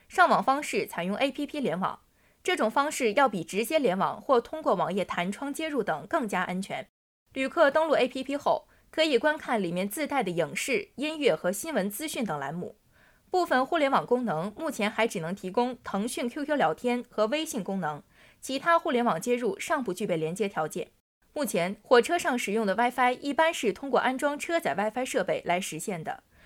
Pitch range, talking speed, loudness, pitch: 200-300 Hz, 305 characters per minute, -28 LUFS, 250 Hz